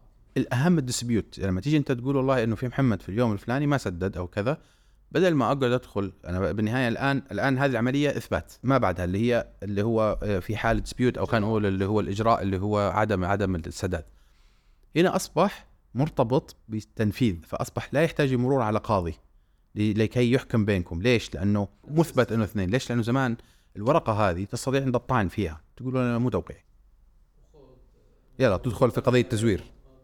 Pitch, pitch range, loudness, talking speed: 115 Hz, 100-130 Hz, -26 LUFS, 170 wpm